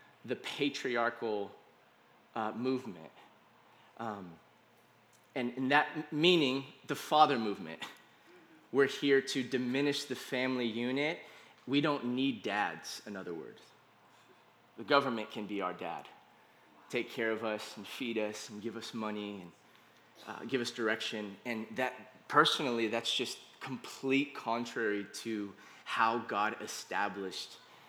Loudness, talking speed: -34 LUFS, 125 wpm